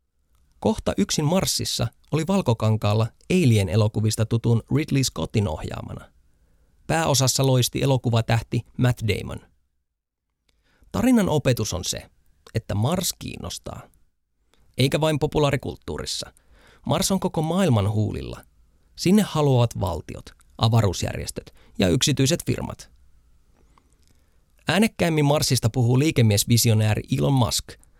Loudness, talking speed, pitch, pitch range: -22 LUFS, 95 wpm, 115 Hz, 85-135 Hz